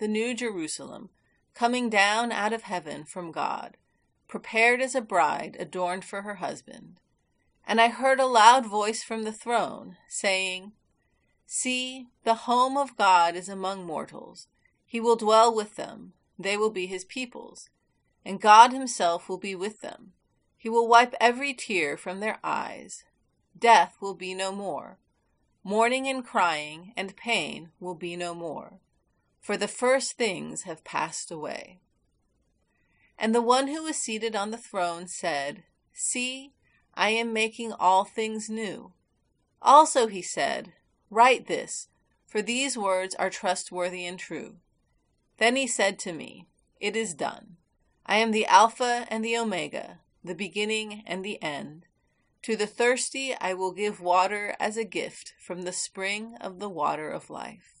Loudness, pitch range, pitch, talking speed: -26 LUFS, 185-235 Hz, 215 Hz, 155 wpm